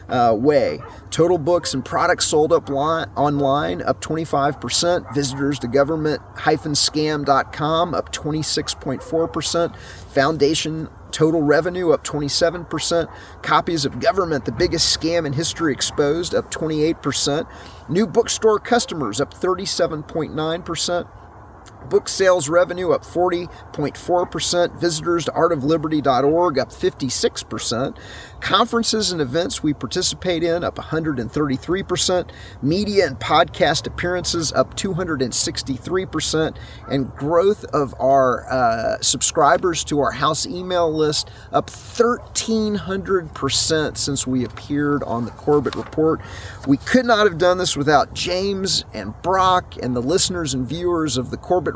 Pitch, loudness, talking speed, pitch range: 155 Hz, -19 LUFS, 115 wpm, 135-175 Hz